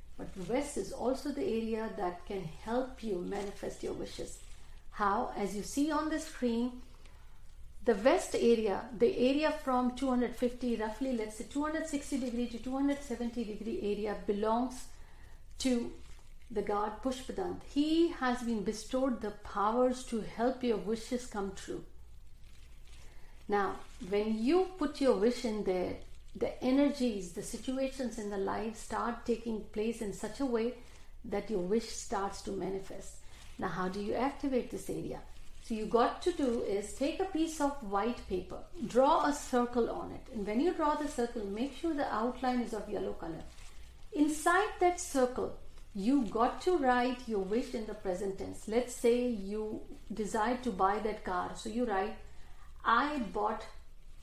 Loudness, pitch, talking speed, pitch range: -34 LUFS, 235 Hz, 160 wpm, 210-260 Hz